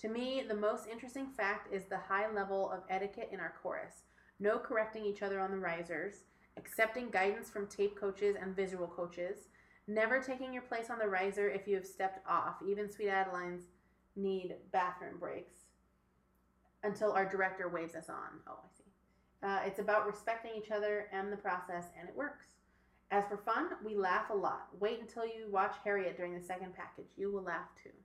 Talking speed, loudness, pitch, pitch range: 190 wpm, -38 LUFS, 200 Hz, 185-215 Hz